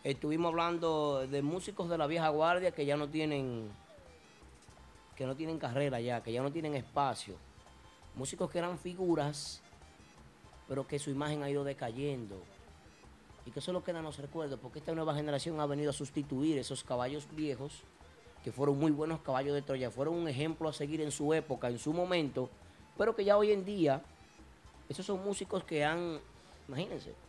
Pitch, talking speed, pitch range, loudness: 145 Hz, 185 wpm, 135-160 Hz, -36 LUFS